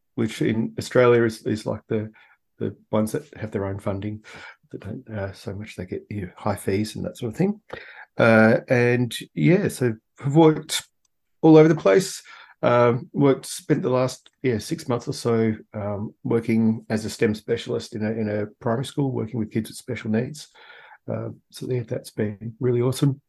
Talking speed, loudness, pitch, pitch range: 195 wpm, -23 LUFS, 115 Hz, 110-130 Hz